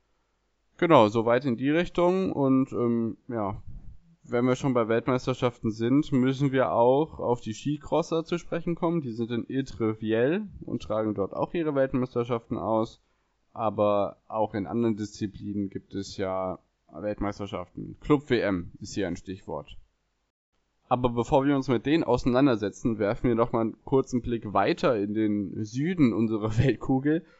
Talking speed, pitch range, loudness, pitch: 155 wpm, 105-135 Hz, -27 LUFS, 120 Hz